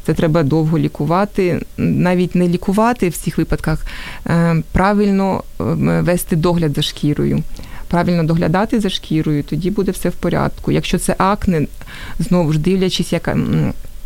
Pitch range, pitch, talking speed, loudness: 155-185 Hz, 175 Hz, 130 wpm, -17 LUFS